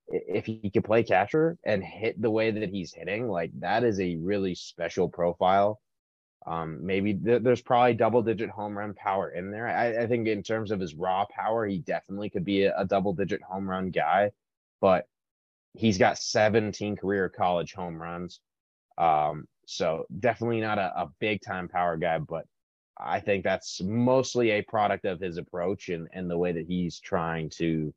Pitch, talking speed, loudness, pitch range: 100 Hz, 185 wpm, -28 LUFS, 90-115 Hz